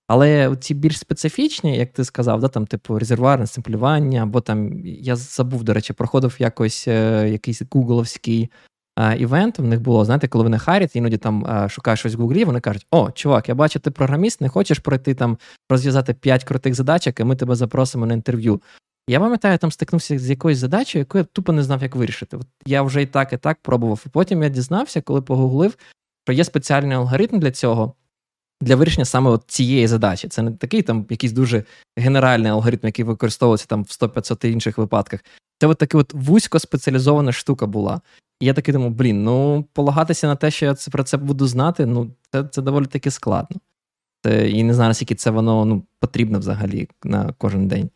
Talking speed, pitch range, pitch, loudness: 200 wpm, 115-145 Hz, 130 Hz, -19 LUFS